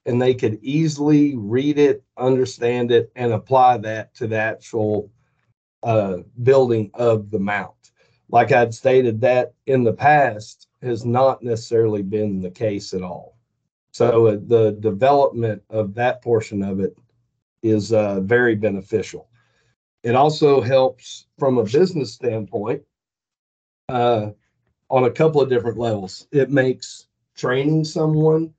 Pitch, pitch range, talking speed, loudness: 120 Hz, 110-130 Hz, 135 wpm, -19 LUFS